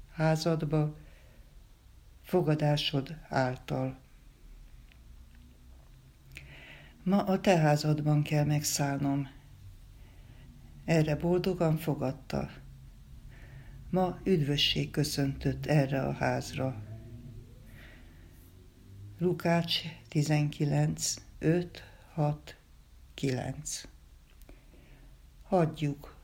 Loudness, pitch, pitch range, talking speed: -30 LUFS, 135 Hz, 95-150 Hz, 55 wpm